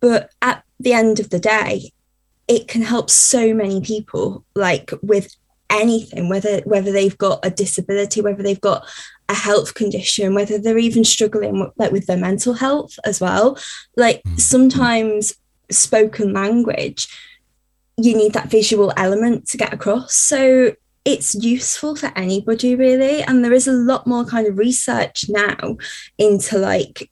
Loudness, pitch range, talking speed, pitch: -16 LUFS, 200-240 Hz, 155 wpm, 215 Hz